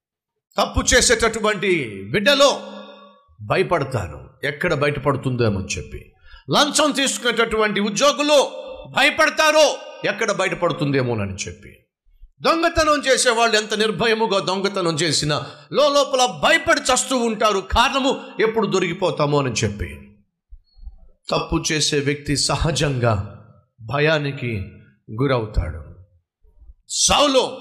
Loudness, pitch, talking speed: -19 LUFS, 175 Hz, 80 wpm